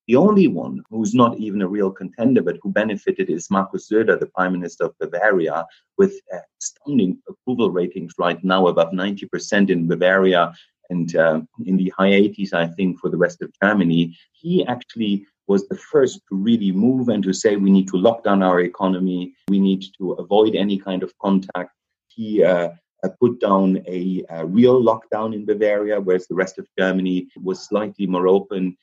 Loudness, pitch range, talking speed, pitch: -19 LUFS, 90-105 Hz, 185 wpm, 95 Hz